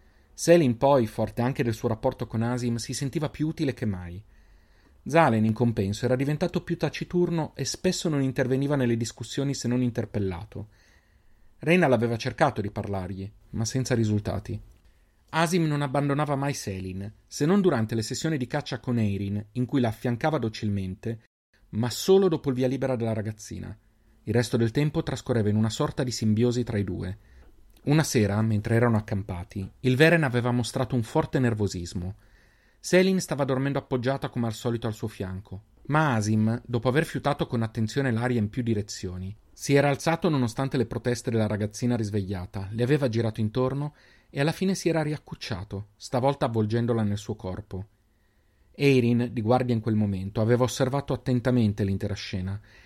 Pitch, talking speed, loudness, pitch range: 120 Hz, 165 wpm, -26 LUFS, 105-135 Hz